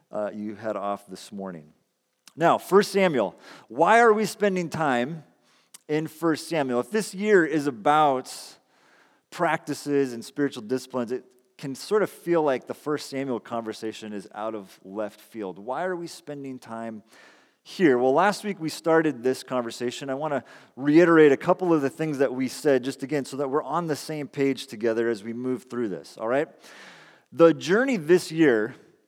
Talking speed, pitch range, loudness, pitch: 180 wpm, 120-160 Hz, -24 LUFS, 140 Hz